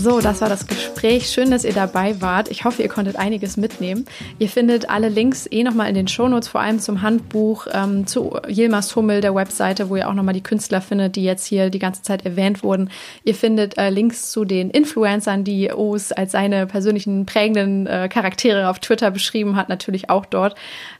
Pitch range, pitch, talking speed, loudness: 195-225 Hz, 205 Hz, 205 wpm, -19 LUFS